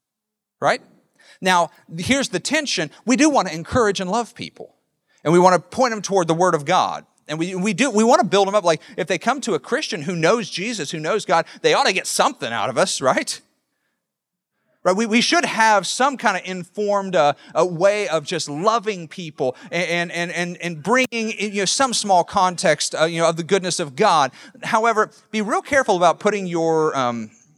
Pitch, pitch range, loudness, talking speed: 195 Hz, 170-225 Hz, -19 LUFS, 215 wpm